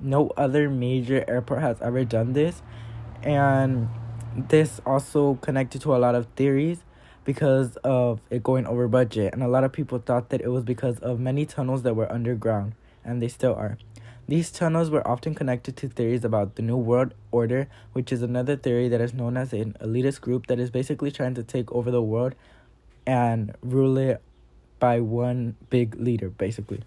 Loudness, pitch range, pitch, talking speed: -25 LUFS, 115-135 Hz, 125 Hz, 185 wpm